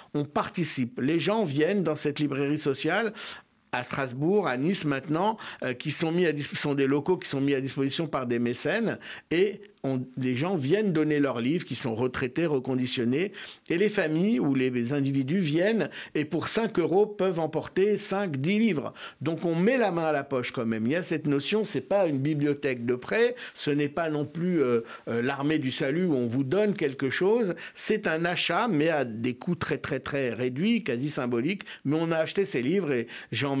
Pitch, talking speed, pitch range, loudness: 150 Hz, 210 wpm, 135-185 Hz, -27 LUFS